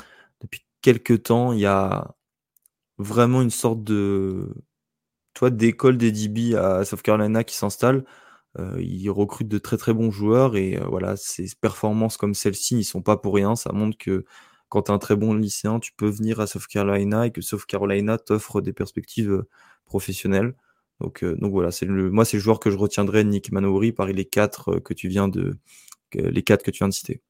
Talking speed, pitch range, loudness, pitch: 195 wpm, 100-115 Hz, -22 LUFS, 105 Hz